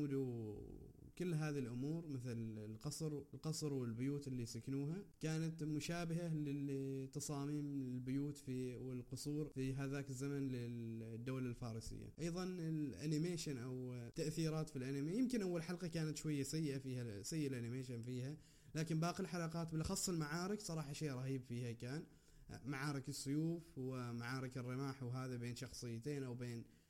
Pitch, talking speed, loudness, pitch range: 140 Hz, 125 wpm, -45 LUFS, 125-155 Hz